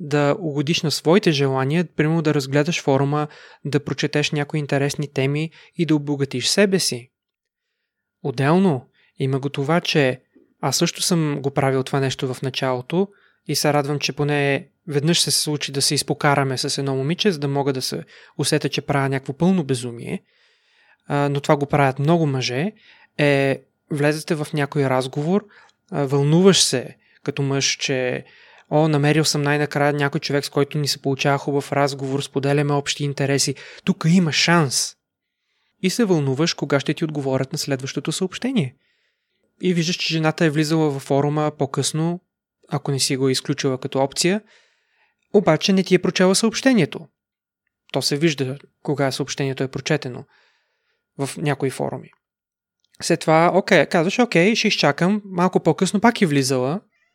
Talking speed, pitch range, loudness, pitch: 155 wpm, 140-170 Hz, -20 LUFS, 145 Hz